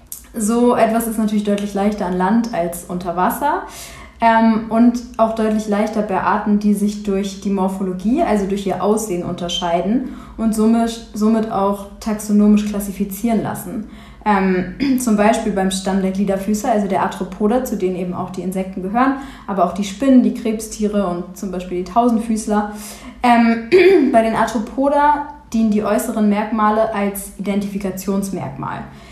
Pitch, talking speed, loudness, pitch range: 210 Hz, 140 wpm, -18 LUFS, 195-230 Hz